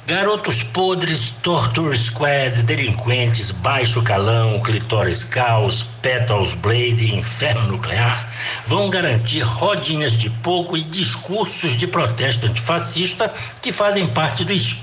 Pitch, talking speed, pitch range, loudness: 120 Hz, 110 wpm, 115-165 Hz, -18 LUFS